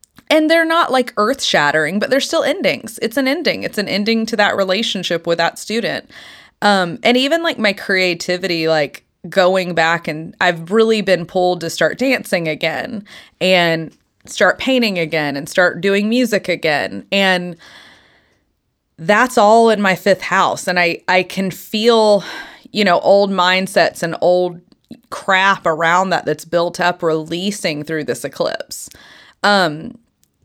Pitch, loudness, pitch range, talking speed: 190 Hz, -15 LUFS, 170-225 Hz, 155 wpm